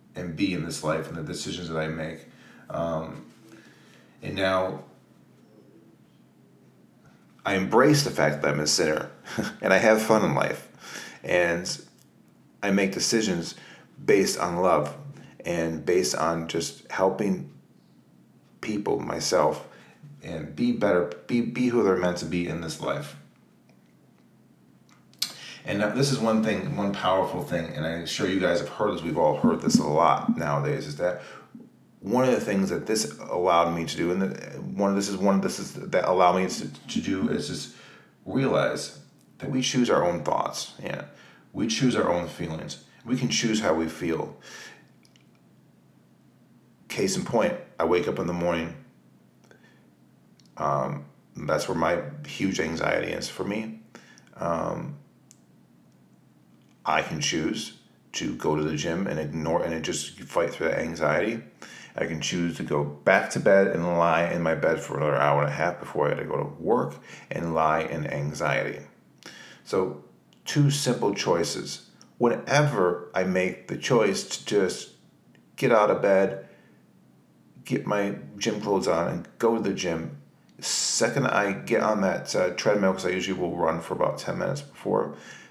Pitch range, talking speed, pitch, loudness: 80-100 Hz, 165 wpm, 90 Hz, -26 LUFS